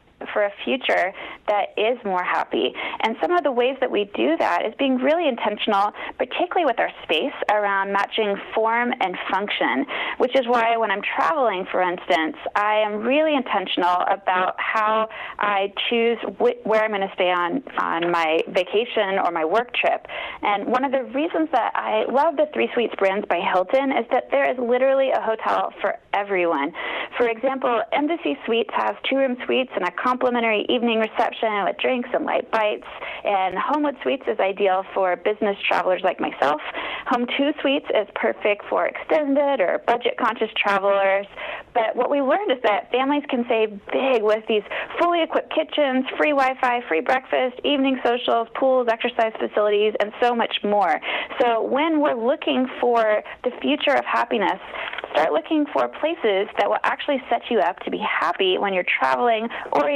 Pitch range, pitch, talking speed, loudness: 205-270 Hz, 235 Hz, 175 wpm, -22 LUFS